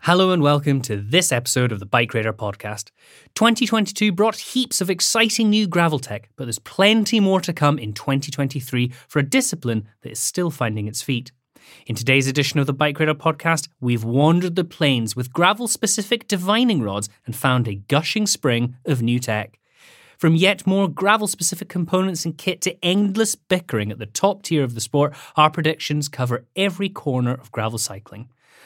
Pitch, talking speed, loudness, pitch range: 150 Hz, 180 wpm, -20 LUFS, 120-190 Hz